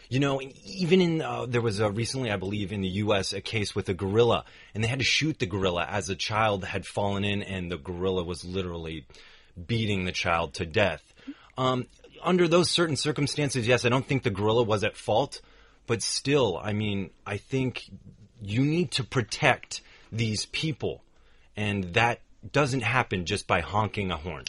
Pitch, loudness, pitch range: 105 Hz, -27 LUFS, 95-130 Hz